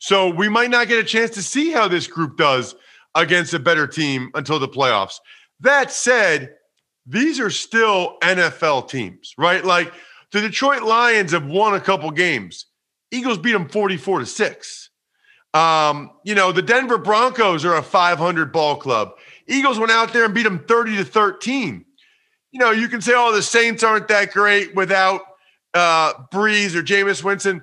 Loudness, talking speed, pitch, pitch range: -17 LUFS, 175 wpm, 205 Hz, 175-230 Hz